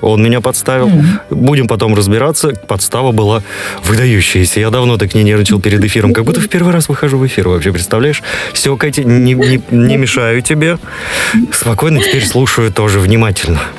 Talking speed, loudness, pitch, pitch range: 165 wpm, -10 LUFS, 120 Hz, 105-135 Hz